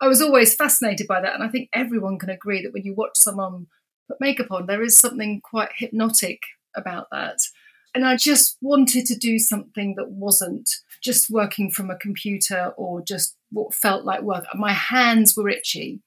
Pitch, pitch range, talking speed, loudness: 220 Hz, 200-255 Hz, 190 wpm, -19 LUFS